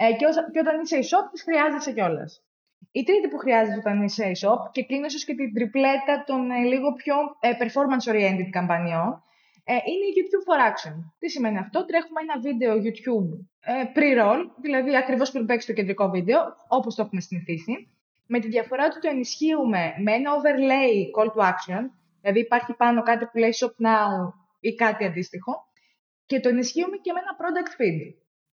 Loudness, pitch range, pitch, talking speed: -24 LUFS, 210-295 Hz, 245 Hz, 180 wpm